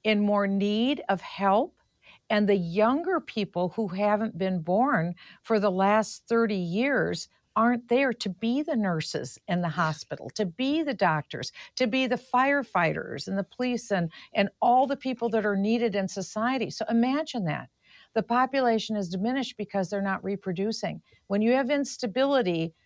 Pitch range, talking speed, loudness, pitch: 195-250 Hz, 165 wpm, -27 LUFS, 215 Hz